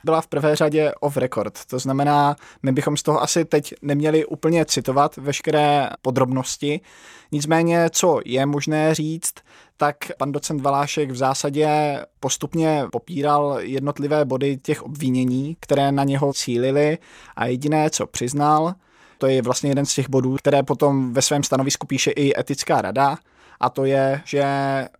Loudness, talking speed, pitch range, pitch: -21 LUFS, 155 wpm, 135-150 Hz, 145 Hz